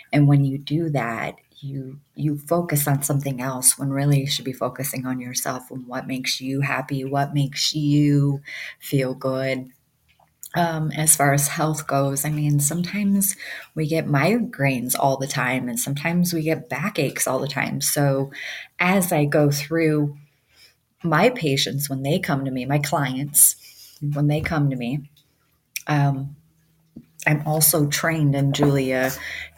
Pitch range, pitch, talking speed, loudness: 135-155 Hz, 145 Hz, 155 wpm, -21 LUFS